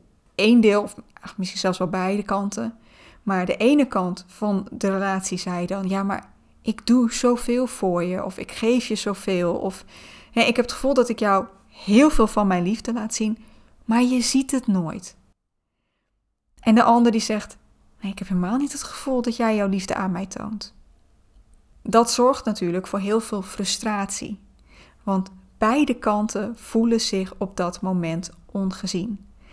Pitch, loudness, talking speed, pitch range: 210 Hz, -22 LUFS, 175 wpm, 195-235 Hz